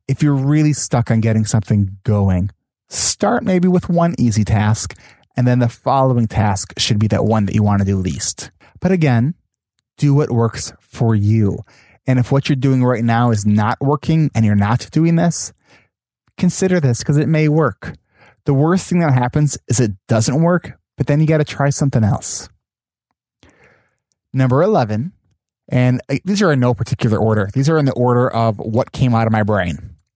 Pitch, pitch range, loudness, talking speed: 125 Hz, 110-145 Hz, -16 LUFS, 190 wpm